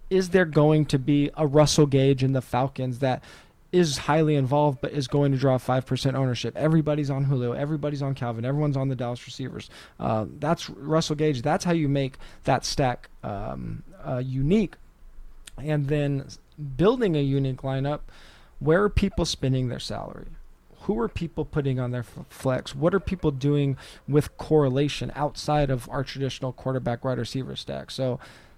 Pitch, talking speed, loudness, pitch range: 140 Hz, 170 wpm, -25 LUFS, 130-150 Hz